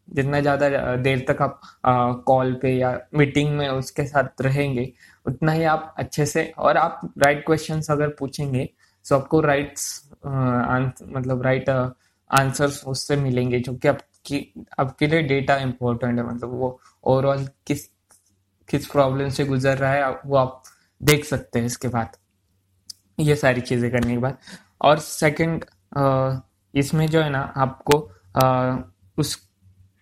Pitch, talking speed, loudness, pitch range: 135 Hz, 155 wpm, -22 LUFS, 125-145 Hz